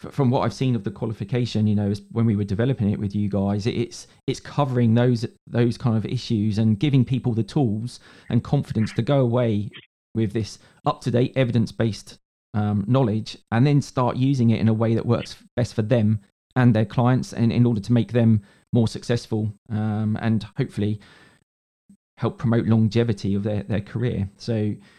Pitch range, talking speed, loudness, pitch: 105-125 Hz, 185 wpm, -23 LUFS, 115 Hz